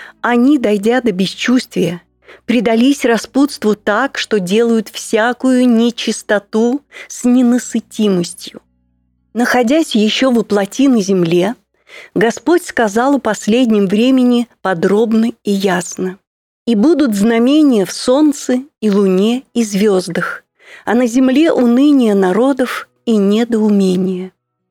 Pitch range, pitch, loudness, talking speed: 200-250 Hz, 230 Hz, -13 LUFS, 105 wpm